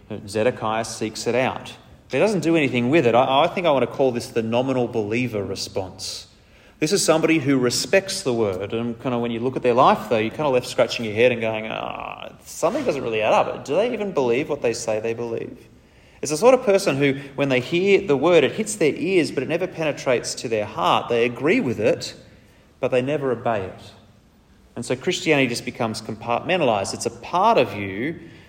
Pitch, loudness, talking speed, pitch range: 125 Hz, -21 LUFS, 225 wpm, 115-160 Hz